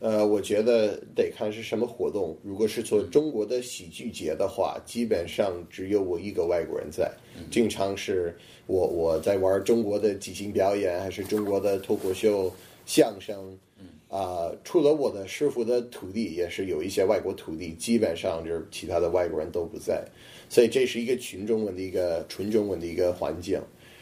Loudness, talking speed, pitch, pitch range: -27 LUFS, 280 characters per minute, 100 Hz, 95-115 Hz